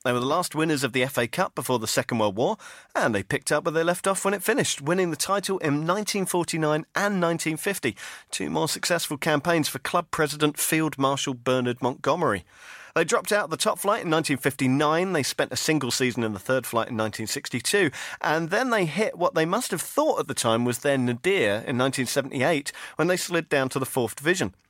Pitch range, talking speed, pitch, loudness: 130-175 Hz, 215 wpm, 150 Hz, -25 LUFS